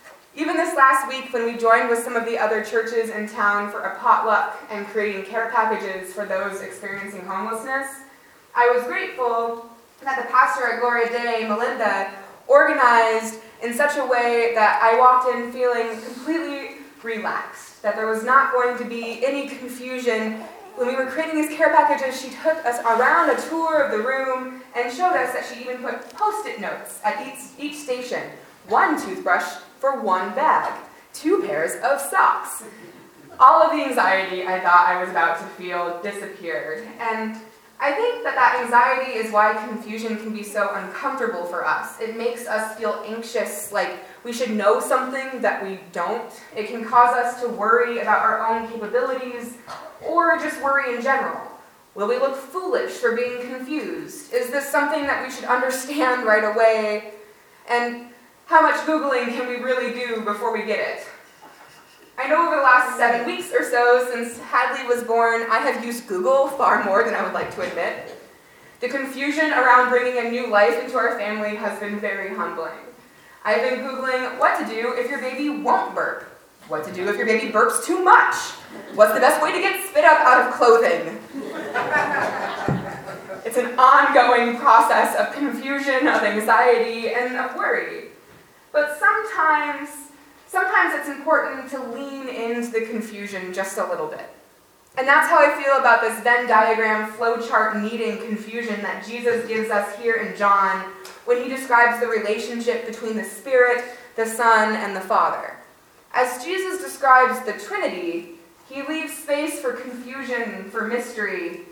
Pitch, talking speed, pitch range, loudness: 240 Hz, 170 wpm, 220-270 Hz, -20 LUFS